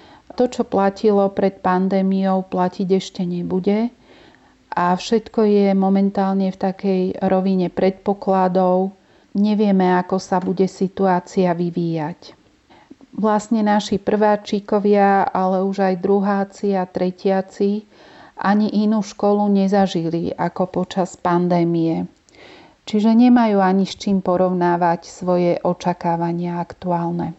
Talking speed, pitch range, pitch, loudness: 105 wpm, 180-205 Hz, 190 Hz, -19 LUFS